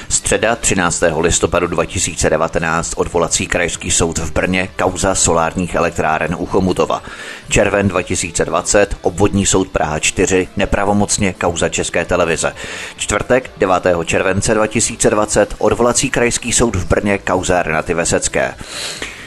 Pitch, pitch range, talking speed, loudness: 95 Hz, 85-100 Hz, 110 wpm, -15 LUFS